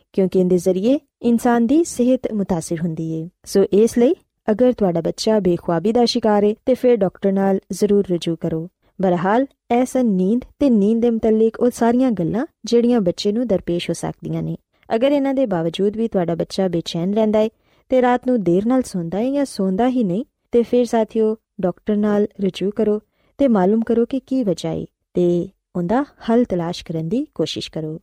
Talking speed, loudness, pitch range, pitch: 185 wpm, -19 LUFS, 180-240 Hz, 215 Hz